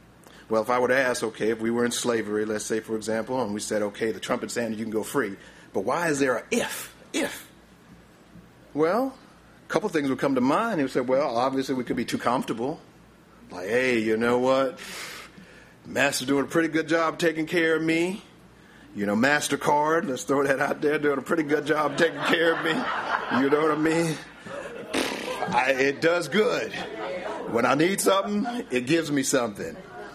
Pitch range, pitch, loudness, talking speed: 120-160 Hz, 140 Hz, -25 LUFS, 205 wpm